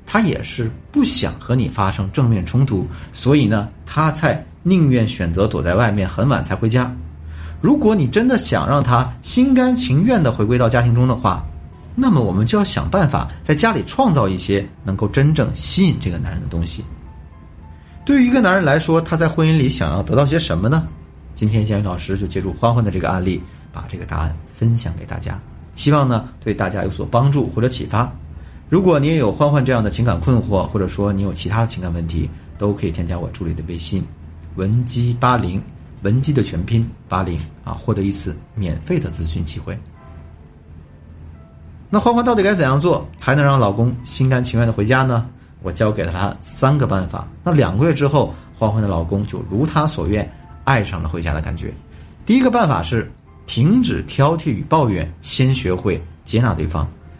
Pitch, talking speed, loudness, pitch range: 105 Hz, 290 characters per minute, -18 LUFS, 85-135 Hz